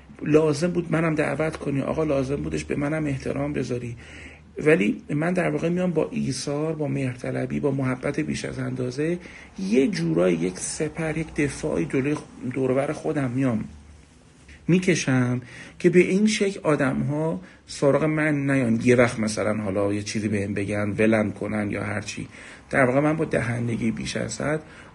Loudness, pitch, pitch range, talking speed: -24 LUFS, 140 Hz, 115-155 Hz, 160 wpm